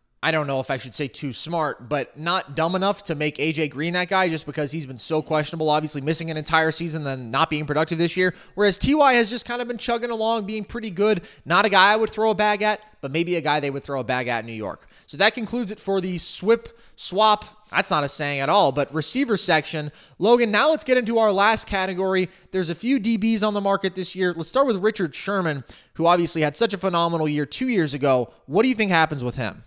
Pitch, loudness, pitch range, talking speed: 175 Hz, -22 LUFS, 150-215 Hz, 255 wpm